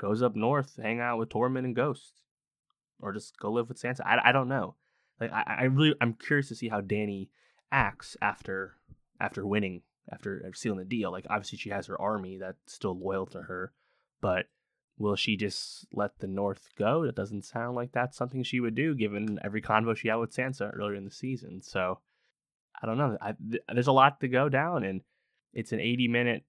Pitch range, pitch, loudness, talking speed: 100-125 Hz, 115 Hz, -30 LUFS, 210 wpm